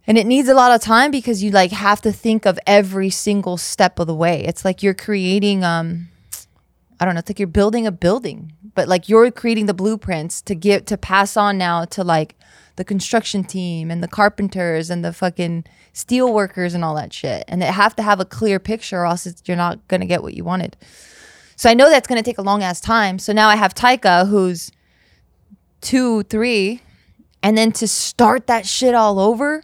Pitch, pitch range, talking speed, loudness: 200 Hz, 175-220 Hz, 220 wpm, -16 LUFS